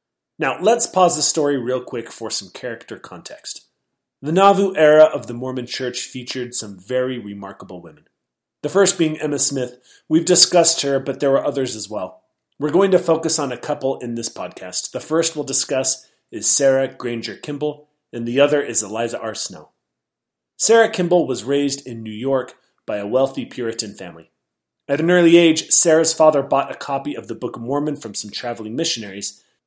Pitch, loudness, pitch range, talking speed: 135 Hz, -18 LUFS, 120-155 Hz, 185 wpm